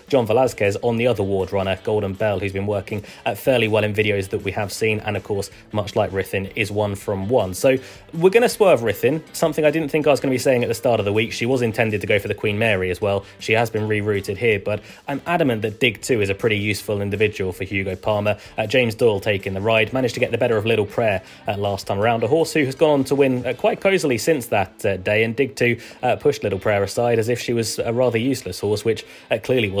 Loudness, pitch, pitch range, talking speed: -20 LUFS, 110 Hz, 100-125 Hz, 275 wpm